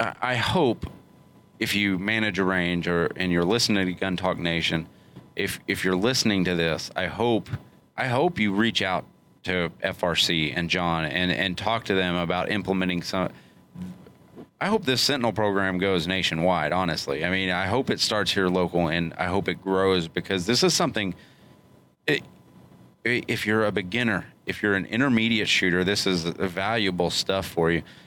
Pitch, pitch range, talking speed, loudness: 95 Hz, 90-105 Hz, 175 wpm, -24 LUFS